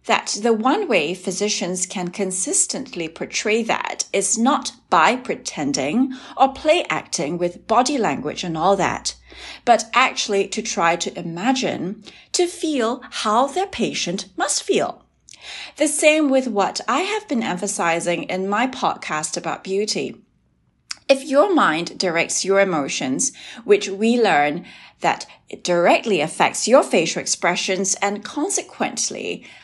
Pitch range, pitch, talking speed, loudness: 180-260 Hz, 205 Hz, 135 wpm, -20 LUFS